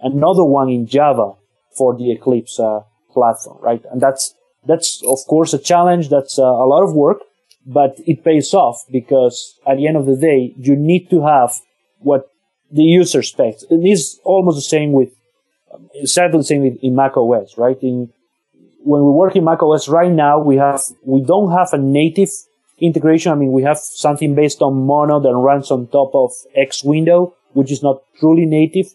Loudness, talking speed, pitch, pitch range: -14 LUFS, 195 wpm, 145 Hz, 130-165 Hz